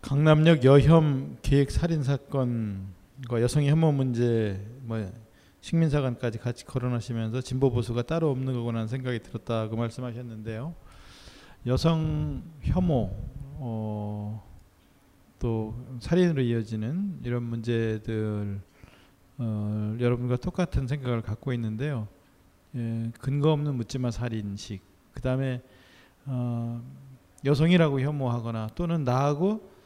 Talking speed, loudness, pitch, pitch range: 255 characters per minute, -27 LUFS, 120 Hz, 110-140 Hz